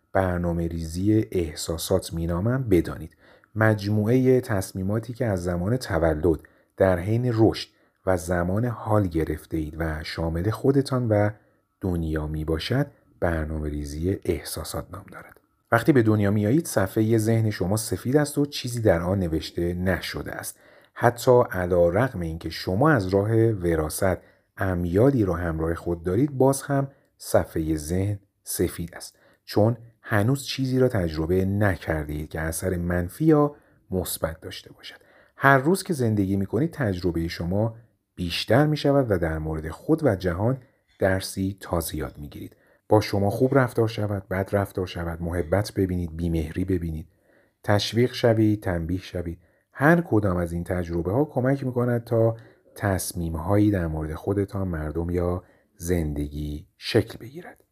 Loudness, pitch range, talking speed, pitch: -24 LUFS, 85-115 Hz, 140 wpm, 95 Hz